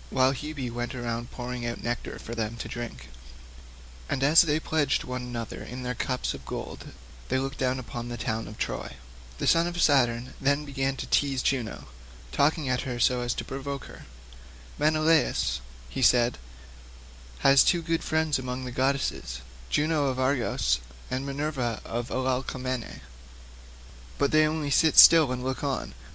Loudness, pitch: -27 LUFS, 120 Hz